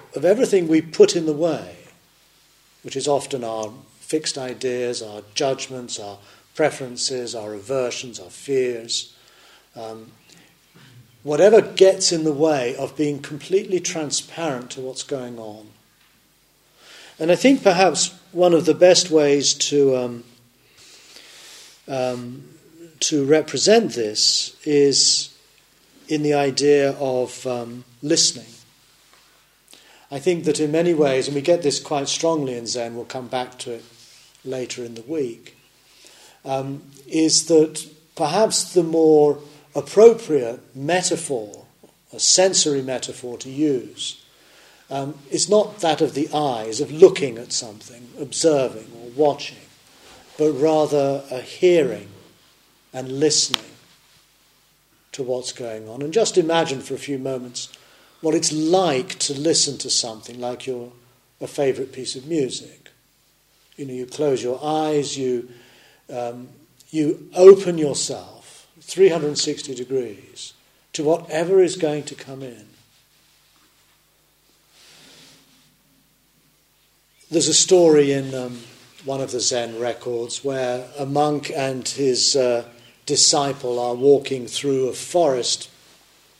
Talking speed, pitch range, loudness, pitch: 125 wpm, 125-155 Hz, -20 LUFS, 140 Hz